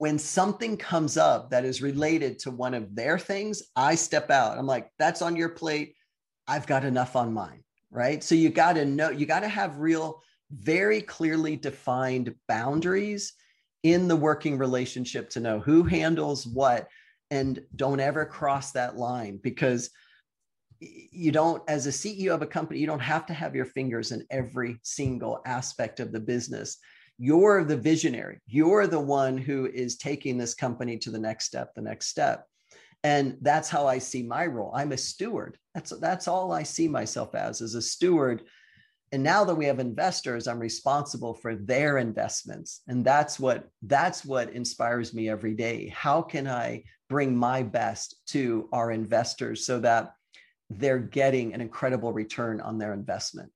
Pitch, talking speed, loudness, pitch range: 135 Hz, 175 wpm, -27 LUFS, 125-160 Hz